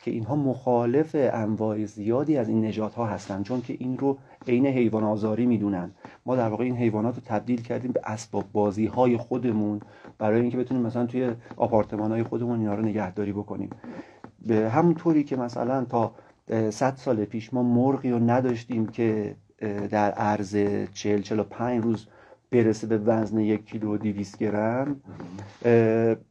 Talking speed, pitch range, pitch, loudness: 160 wpm, 105-125 Hz, 115 Hz, -26 LUFS